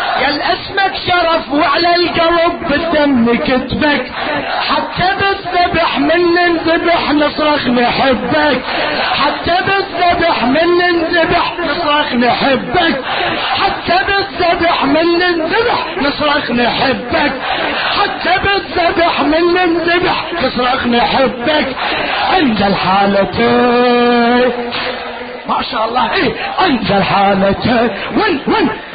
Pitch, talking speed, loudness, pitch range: 315 Hz, 85 wpm, -12 LUFS, 250-350 Hz